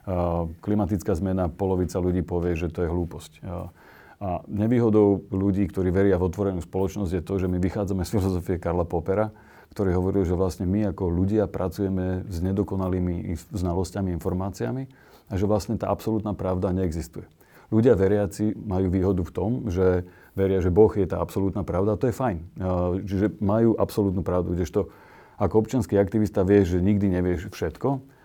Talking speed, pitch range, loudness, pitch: 165 wpm, 90-105 Hz, -25 LUFS, 95 Hz